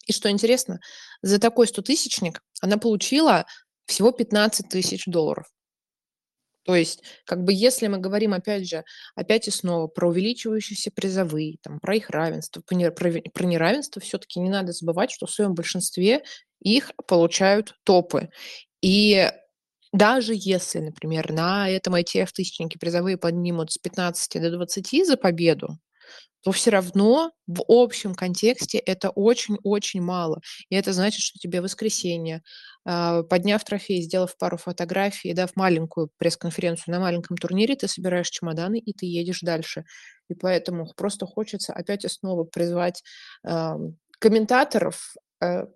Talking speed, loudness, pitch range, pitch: 140 wpm, -23 LUFS, 175-210 Hz, 185 Hz